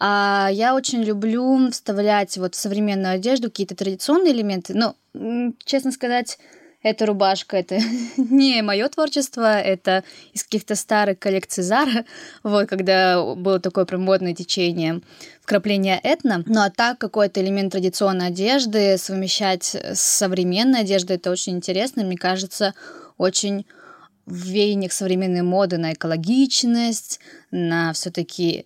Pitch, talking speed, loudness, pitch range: 200 Hz, 125 wpm, -20 LUFS, 185-235 Hz